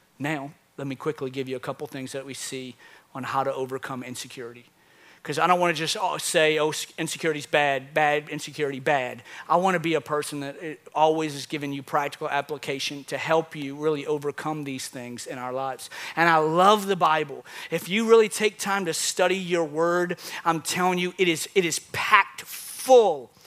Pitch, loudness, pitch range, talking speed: 150 Hz, -25 LUFS, 135-165 Hz, 195 wpm